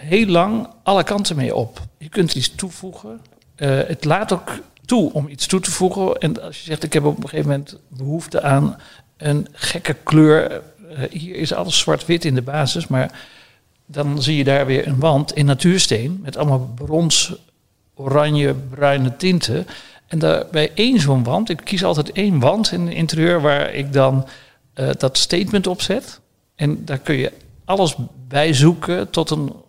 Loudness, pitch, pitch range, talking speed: -18 LUFS, 150 Hz, 135-175 Hz, 175 wpm